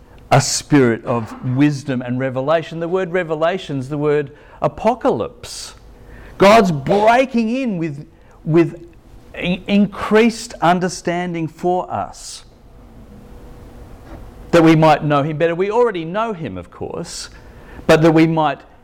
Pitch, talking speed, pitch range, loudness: 165 Hz, 120 wpm, 145-185 Hz, -17 LUFS